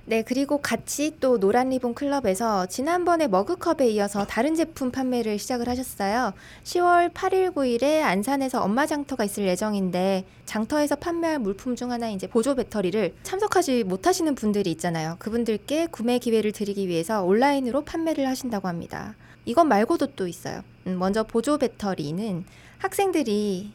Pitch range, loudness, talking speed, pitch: 200-290 Hz, -24 LUFS, 365 characters per minute, 240 Hz